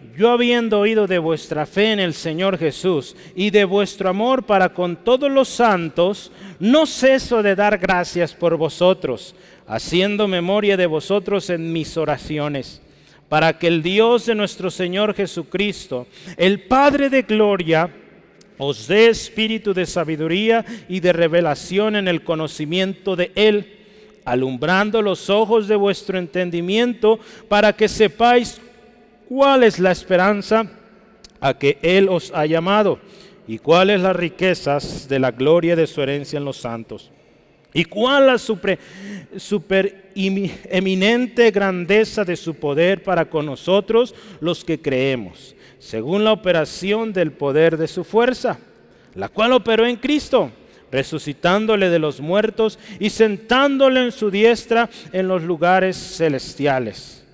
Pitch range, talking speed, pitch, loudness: 165-215 Hz, 140 wpm, 190 Hz, -18 LUFS